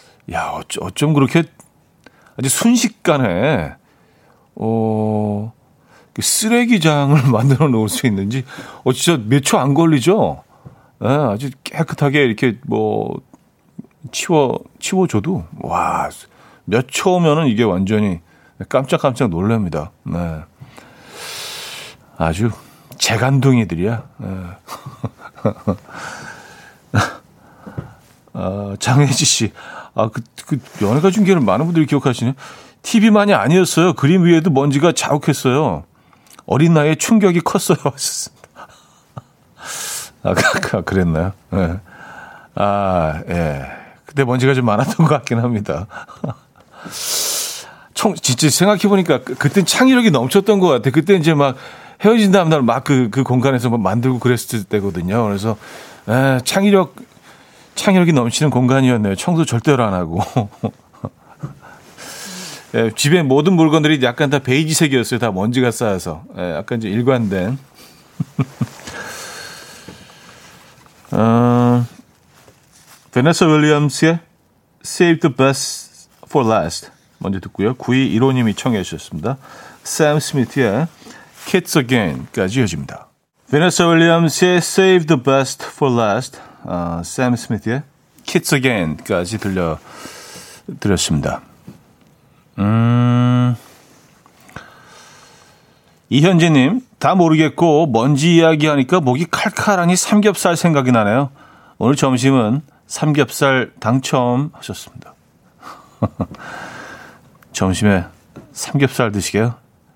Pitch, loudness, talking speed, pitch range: 135 Hz, -16 LUFS, 245 characters per minute, 115-160 Hz